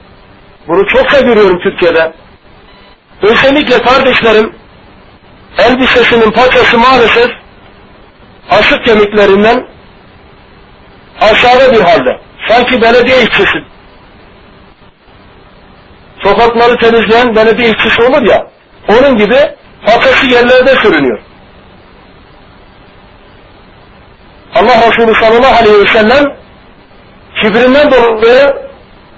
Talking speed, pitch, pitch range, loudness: 75 wpm, 240 Hz, 225-260 Hz, -6 LUFS